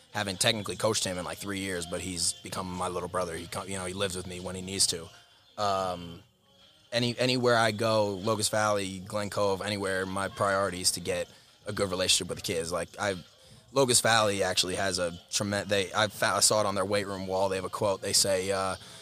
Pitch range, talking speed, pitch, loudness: 90-105 Hz, 220 wpm, 95 Hz, -28 LUFS